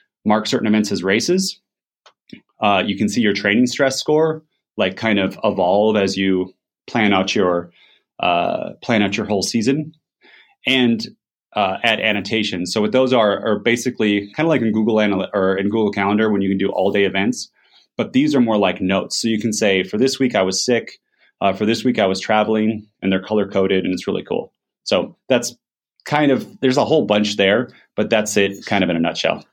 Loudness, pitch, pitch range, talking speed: -18 LUFS, 105 Hz, 95-125 Hz, 210 wpm